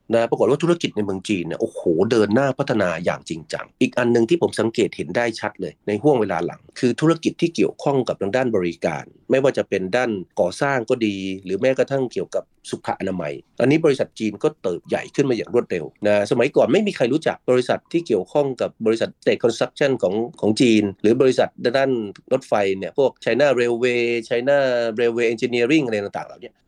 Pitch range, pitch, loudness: 105-130 Hz, 120 Hz, -21 LUFS